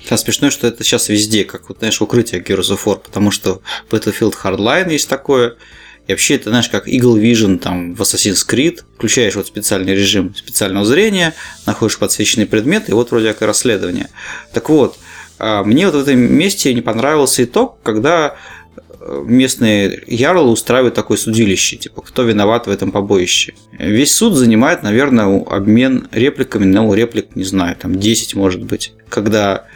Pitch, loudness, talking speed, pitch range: 110 Hz, -13 LUFS, 160 wpm, 100-120 Hz